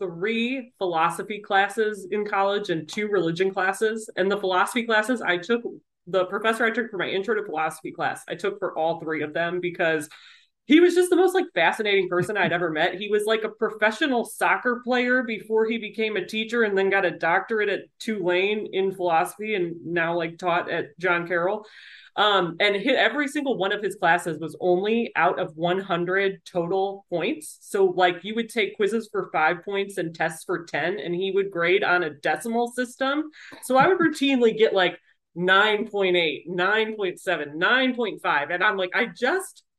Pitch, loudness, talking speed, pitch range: 195 Hz, -24 LUFS, 185 wpm, 180-225 Hz